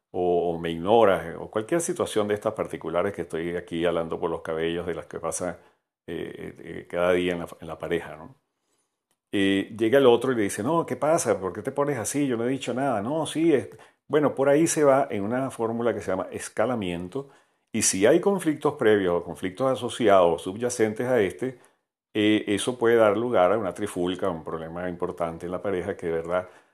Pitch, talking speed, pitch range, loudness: 105 Hz, 215 wpm, 90-125 Hz, -25 LUFS